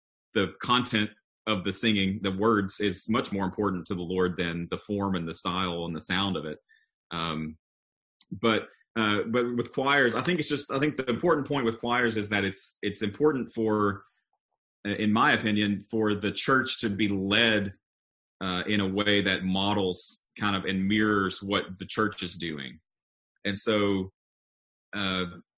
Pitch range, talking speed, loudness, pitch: 95-110 Hz, 175 wpm, -27 LUFS, 100 Hz